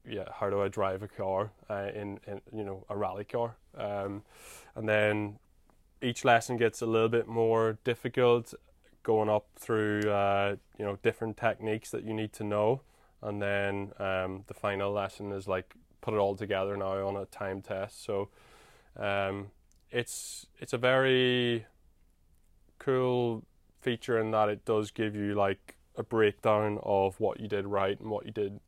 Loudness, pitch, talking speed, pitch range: -31 LUFS, 105 Hz, 170 wpm, 100-110 Hz